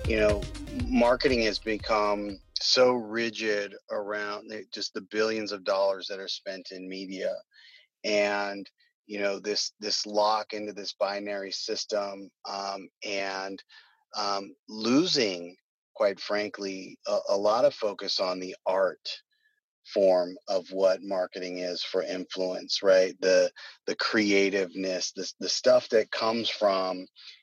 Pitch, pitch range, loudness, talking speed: 100 Hz, 95-105 Hz, -28 LUFS, 130 wpm